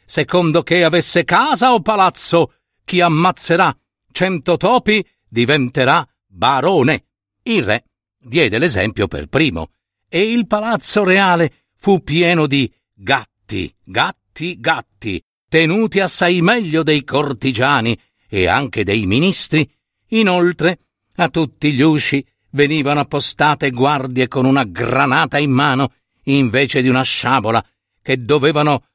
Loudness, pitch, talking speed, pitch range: -15 LUFS, 145 Hz, 115 wpm, 130-175 Hz